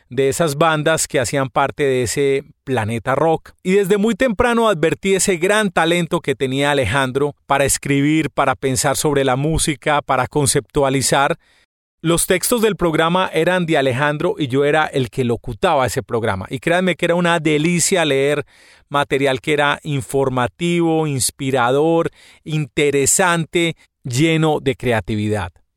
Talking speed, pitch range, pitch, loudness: 140 wpm, 135-165 Hz, 145 Hz, -17 LUFS